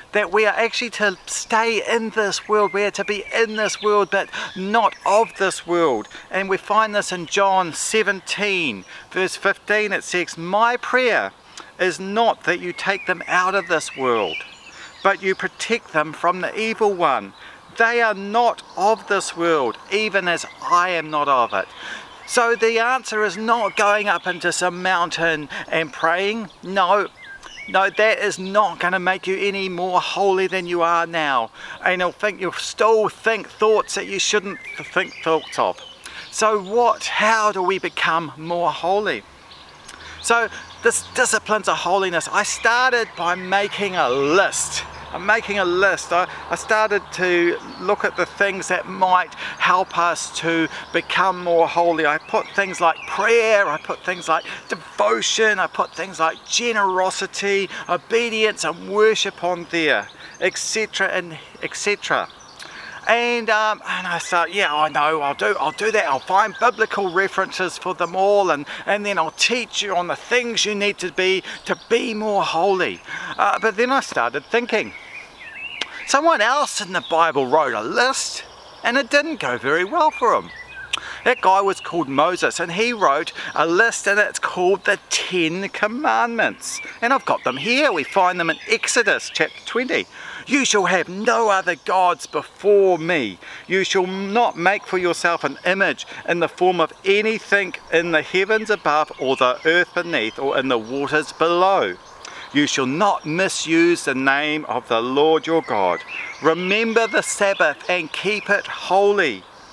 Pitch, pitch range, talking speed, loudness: 195 Hz, 175-215 Hz, 165 wpm, -19 LUFS